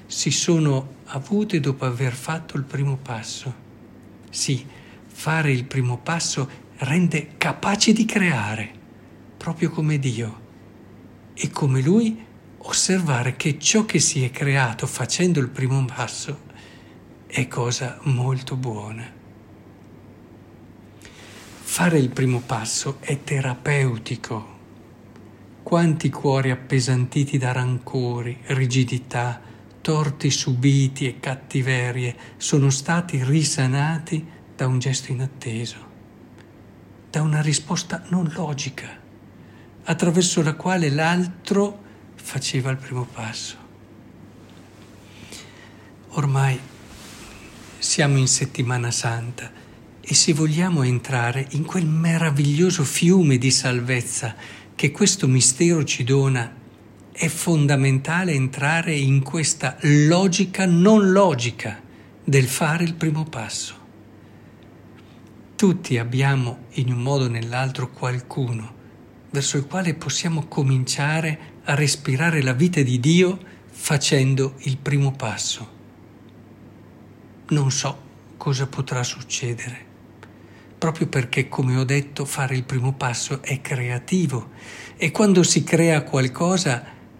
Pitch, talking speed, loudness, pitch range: 130 Hz, 105 wpm, -21 LUFS, 115-150 Hz